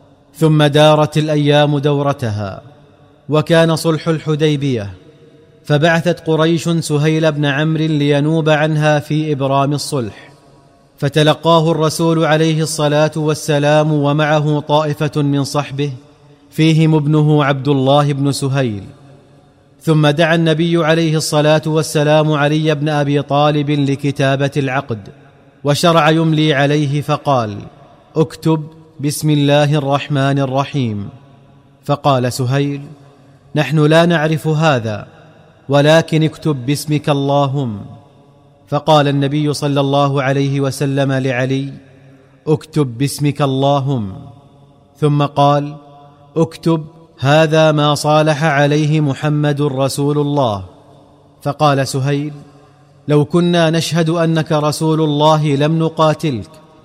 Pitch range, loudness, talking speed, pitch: 140-155 Hz, -14 LUFS, 100 wpm, 145 Hz